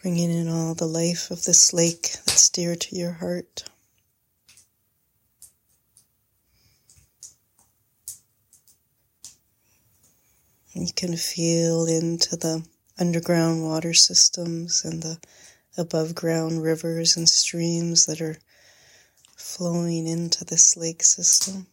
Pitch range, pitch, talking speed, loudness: 120-170 Hz, 165 Hz, 95 wpm, -20 LUFS